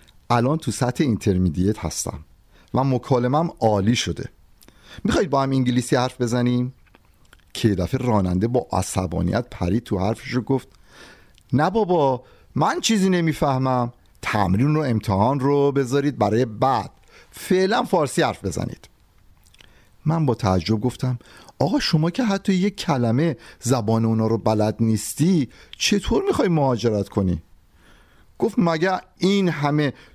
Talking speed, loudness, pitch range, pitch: 125 wpm, -21 LUFS, 100-145 Hz, 125 Hz